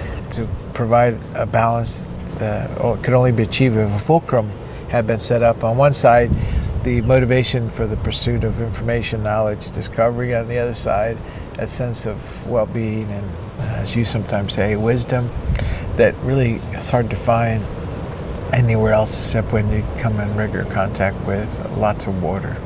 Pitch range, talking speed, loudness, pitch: 105-120 Hz, 165 wpm, -19 LUFS, 115 Hz